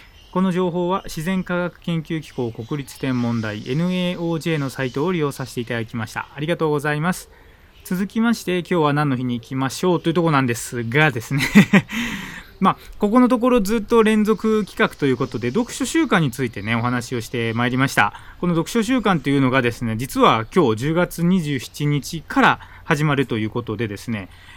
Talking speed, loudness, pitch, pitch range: 380 characters per minute, -20 LUFS, 150 Hz, 125-180 Hz